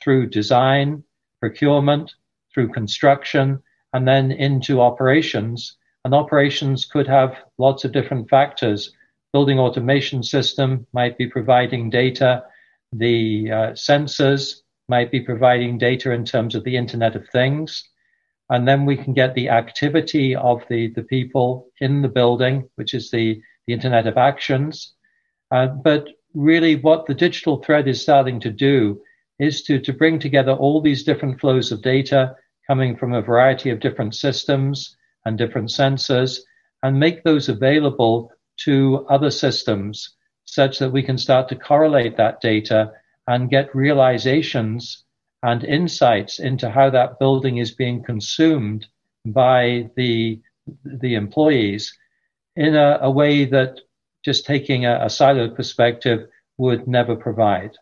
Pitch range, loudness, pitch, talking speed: 120-140 Hz, -18 LUFS, 130 Hz, 140 wpm